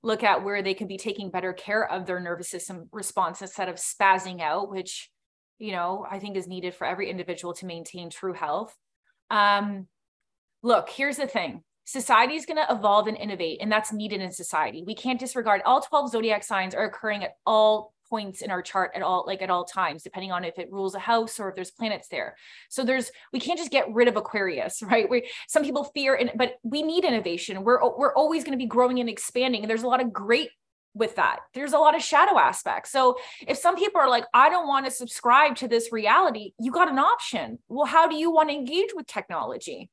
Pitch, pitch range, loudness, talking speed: 220 Hz, 190-260 Hz, -25 LUFS, 225 wpm